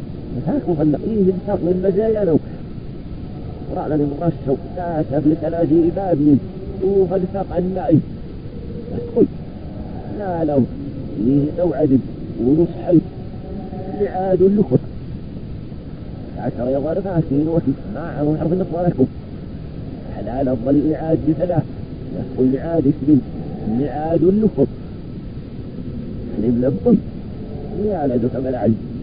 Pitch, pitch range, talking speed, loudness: 155 Hz, 135-180 Hz, 100 wpm, -19 LUFS